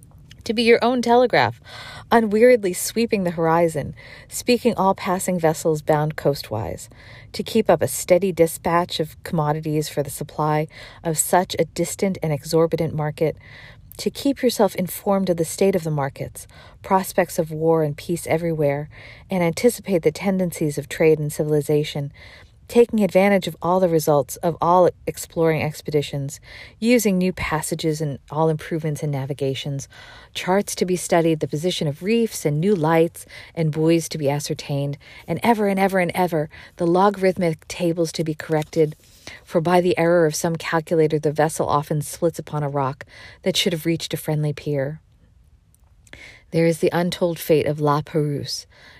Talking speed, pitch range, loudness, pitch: 160 wpm, 145-180 Hz, -21 LUFS, 160 Hz